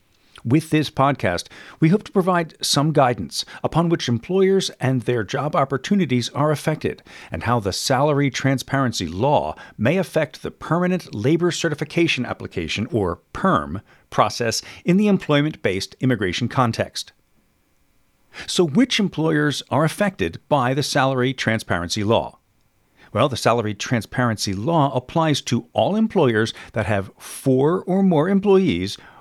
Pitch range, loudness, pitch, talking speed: 110-160 Hz, -20 LUFS, 135 Hz, 135 wpm